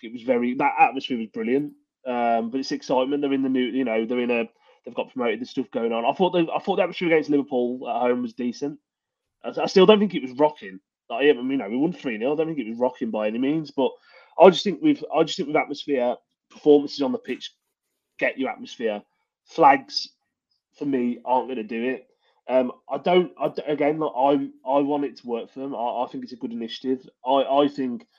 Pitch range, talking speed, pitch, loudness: 125-150 Hz, 240 wpm, 140 Hz, -23 LUFS